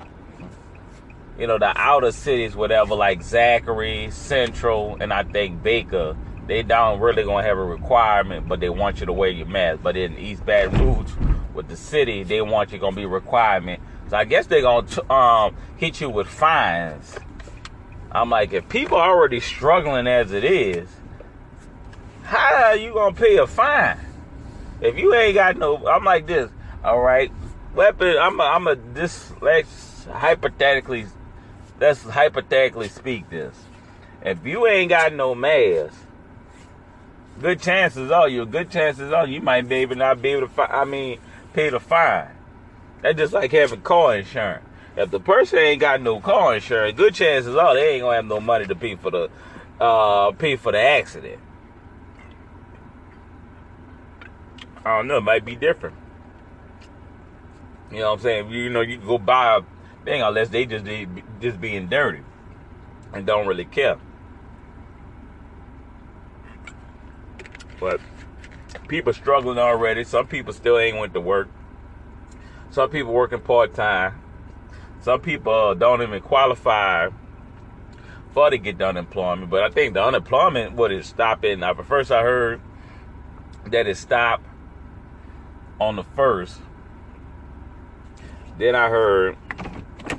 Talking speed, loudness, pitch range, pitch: 150 wpm, -19 LUFS, 90-130 Hz, 105 Hz